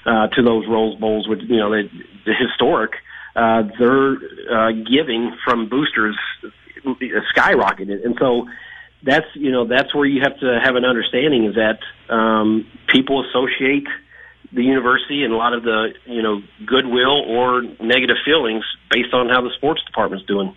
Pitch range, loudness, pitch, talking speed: 110-130 Hz, -17 LUFS, 120 Hz, 165 wpm